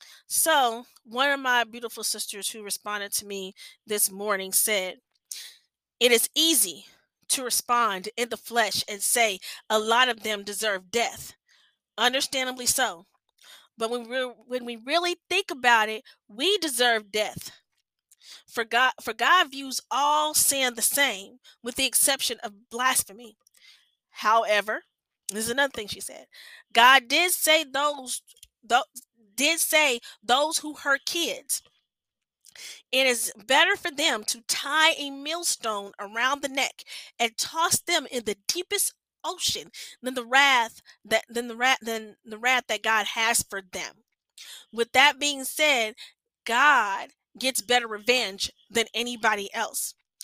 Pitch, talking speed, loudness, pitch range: 245 Hz, 145 wpm, -24 LUFS, 220-285 Hz